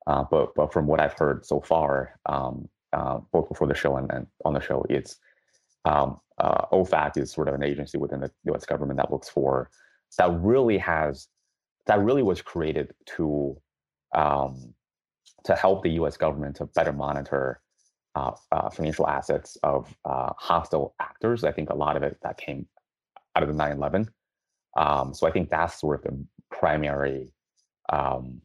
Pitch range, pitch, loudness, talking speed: 70-75 Hz, 70 Hz, -26 LUFS, 175 wpm